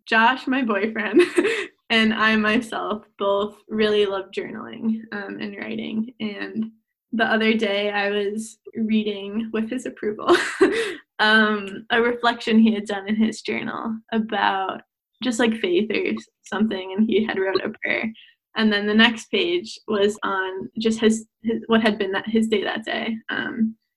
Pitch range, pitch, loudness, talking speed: 210-230 Hz, 220 Hz, -22 LUFS, 160 wpm